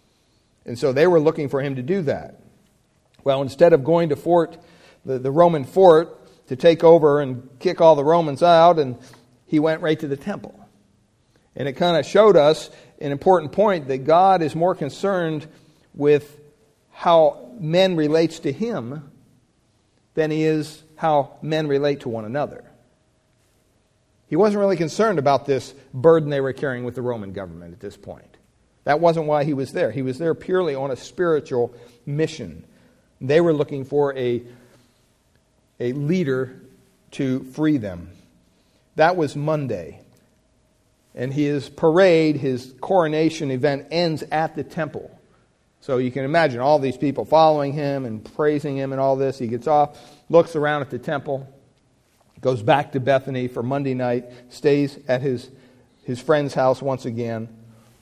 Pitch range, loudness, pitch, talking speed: 125-160 Hz, -20 LUFS, 145 Hz, 160 wpm